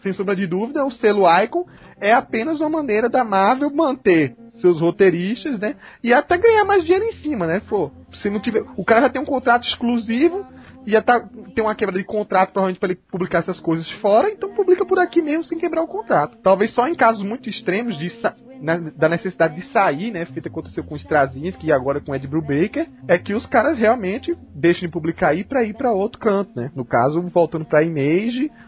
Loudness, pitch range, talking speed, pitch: -19 LUFS, 175-265 Hz, 220 wpm, 215 Hz